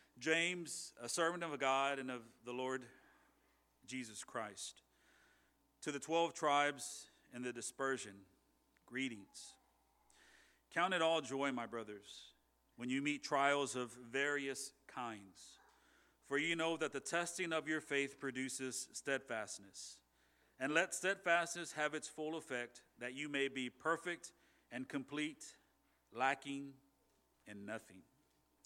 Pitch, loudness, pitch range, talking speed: 135 Hz, -41 LUFS, 120-150 Hz, 125 wpm